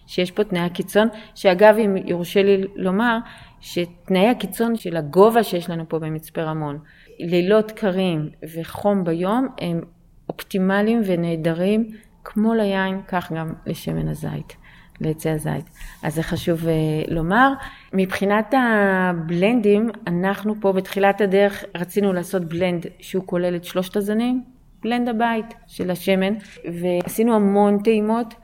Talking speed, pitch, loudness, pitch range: 120 wpm, 190 Hz, -21 LUFS, 175-215 Hz